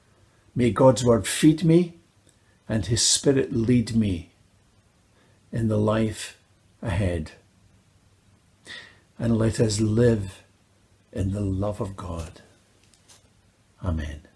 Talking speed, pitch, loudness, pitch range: 100 wpm, 105 Hz, -23 LUFS, 95-115 Hz